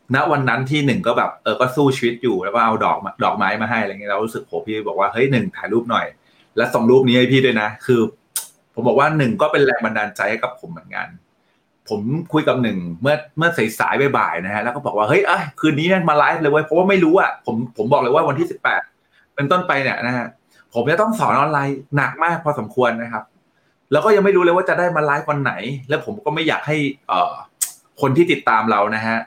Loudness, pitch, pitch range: -18 LUFS, 140 Hz, 120-155 Hz